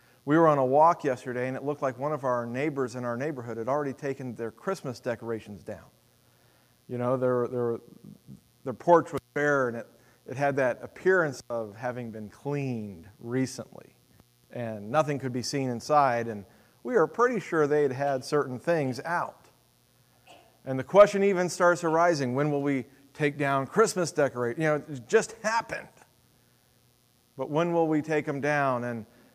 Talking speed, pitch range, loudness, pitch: 175 wpm, 120-150 Hz, -27 LUFS, 135 Hz